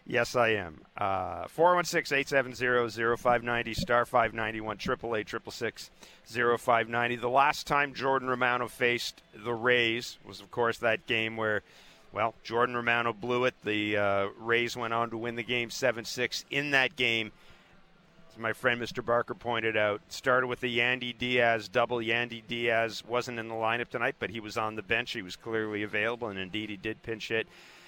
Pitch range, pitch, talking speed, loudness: 110-125 Hz, 120 Hz, 165 wpm, -29 LUFS